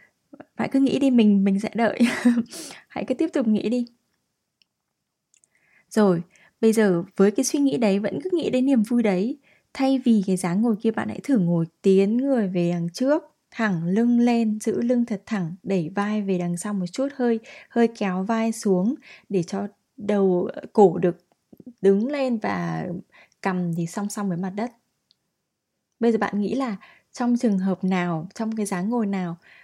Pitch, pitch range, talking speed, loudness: 215 Hz, 190-240 Hz, 185 wpm, -23 LUFS